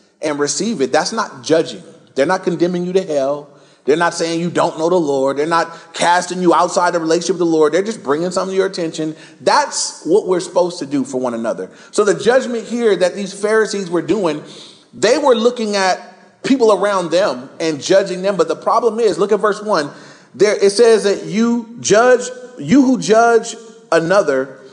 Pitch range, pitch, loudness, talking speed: 165-215 Hz, 180 Hz, -16 LUFS, 200 wpm